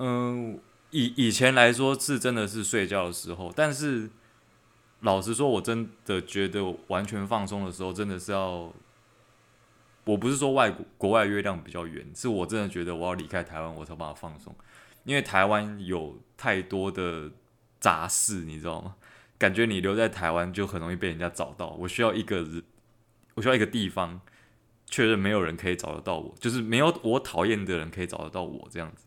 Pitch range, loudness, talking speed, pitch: 90-115 Hz, -28 LUFS, 285 characters per minute, 100 Hz